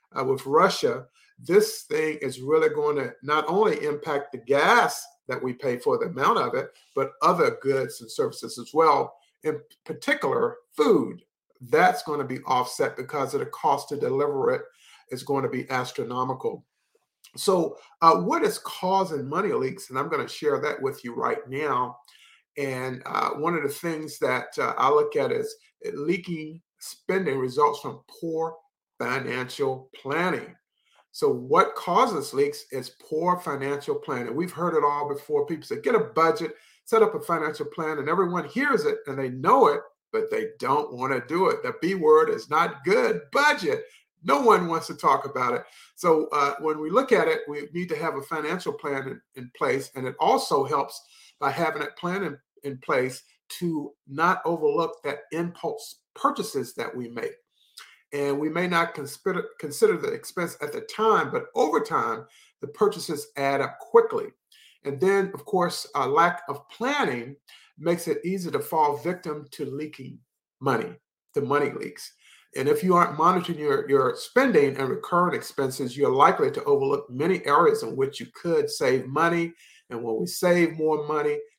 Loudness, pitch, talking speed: -25 LUFS, 210 Hz, 180 wpm